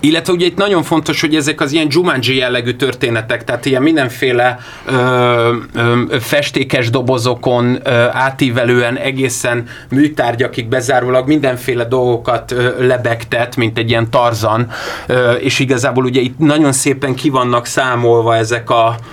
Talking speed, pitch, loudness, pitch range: 130 wpm, 125 Hz, -13 LUFS, 120-135 Hz